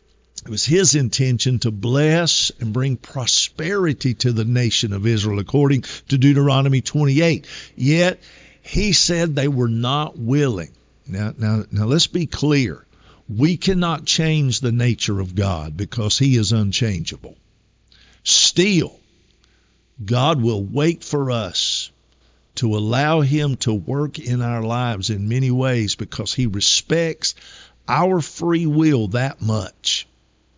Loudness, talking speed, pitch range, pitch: -19 LUFS, 130 wpm, 110-150 Hz, 125 Hz